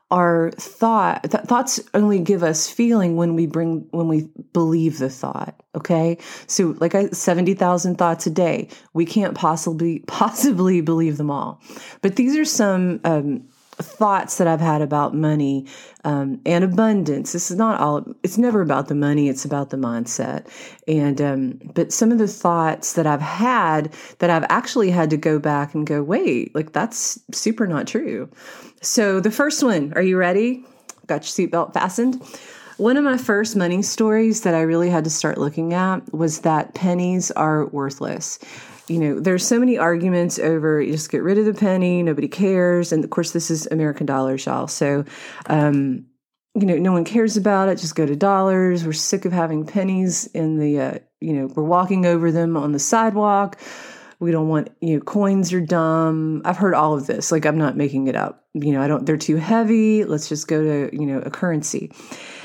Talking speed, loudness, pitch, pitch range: 195 wpm, -20 LUFS, 170 Hz, 155-200 Hz